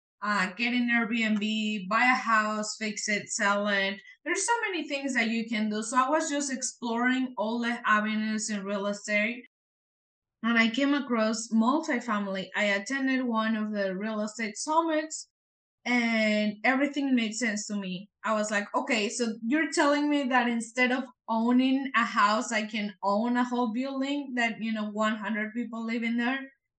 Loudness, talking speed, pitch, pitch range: -28 LUFS, 170 wpm, 230 Hz, 215-255 Hz